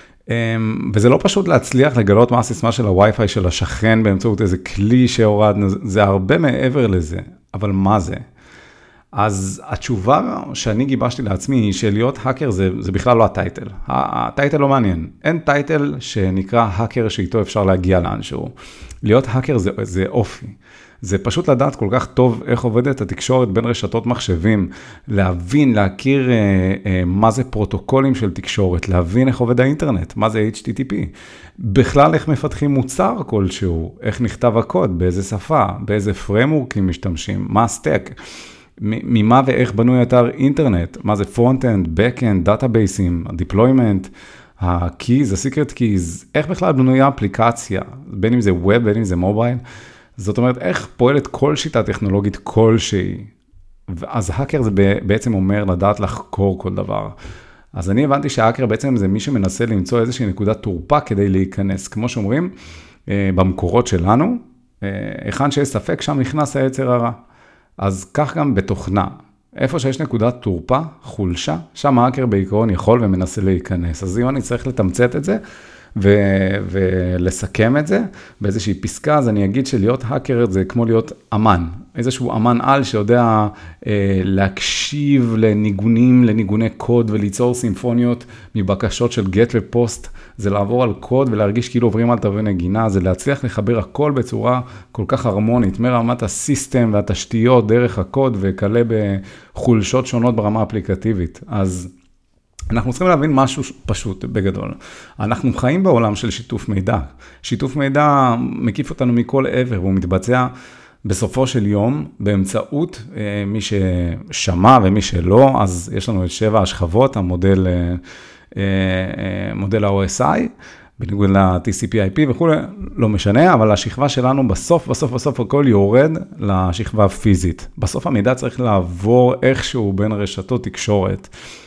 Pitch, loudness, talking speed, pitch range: 110 Hz, -17 LUFS, 140 wpm, 95-125 Hz